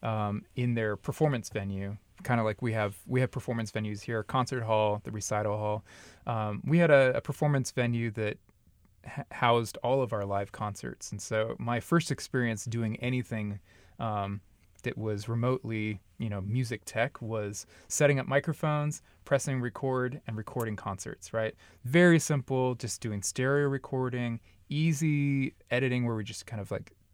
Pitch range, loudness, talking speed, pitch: 105-130 Hz, -31 LUFS, 165 wpm, 115 Hz